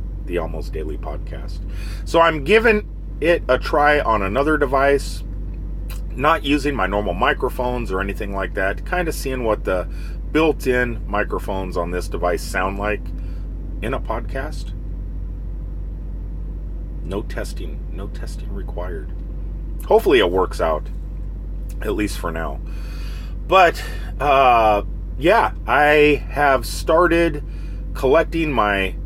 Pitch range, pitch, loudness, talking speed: 85-130 Hz, 95 Hz, -19 LUFS, 120 wpm